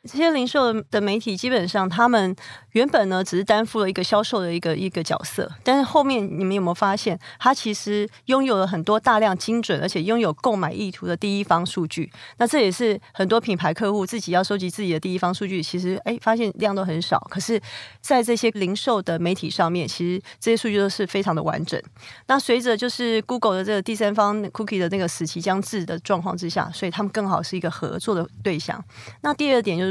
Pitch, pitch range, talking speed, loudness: 200 Hz, 180-225 Hz, 360 characters per minute, -22 LUFS